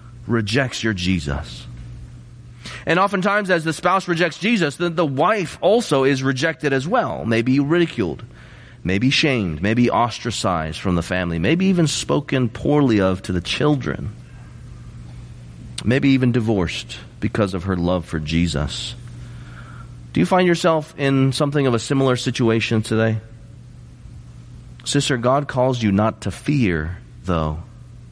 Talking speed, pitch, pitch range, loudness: 135 wpm, 120 Hz, 100-145 Hz, -19 LUFS